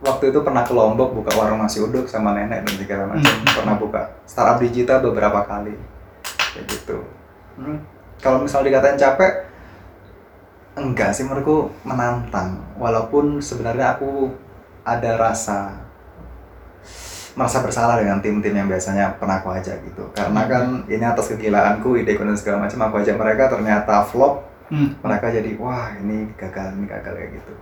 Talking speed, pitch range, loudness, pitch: 150 wpm, 100-125 Hz, -19 LUFS, 110 Hz